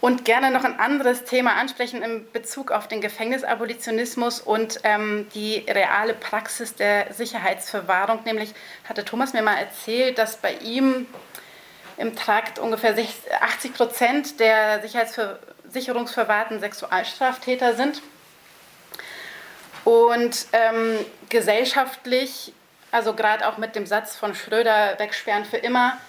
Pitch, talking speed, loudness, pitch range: 230 Hz, 115 wpm, -22 LUFS, 215-245 Hz